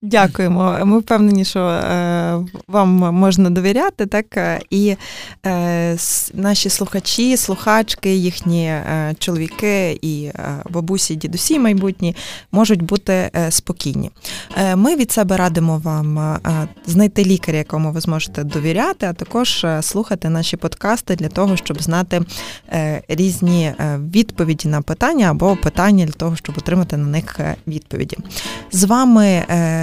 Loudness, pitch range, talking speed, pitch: -17 LUFS, 160-200 Hz, 115 wpm, 180 Hz